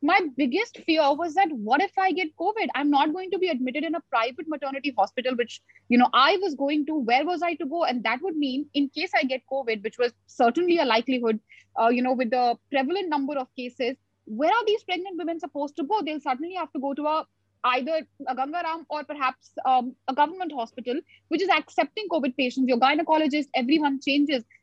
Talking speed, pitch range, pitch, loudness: 220 wpm, 255-335 Hz, 290 Hz, -25 LUFS